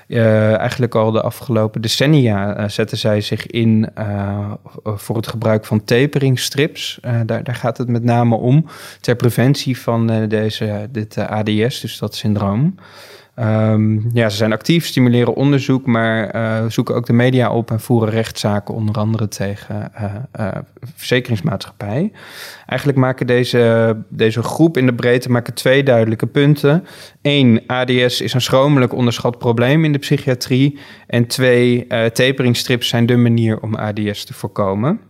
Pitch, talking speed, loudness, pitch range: 120 Hz, 155 wpm, -16 LUFS, 110-130 Hz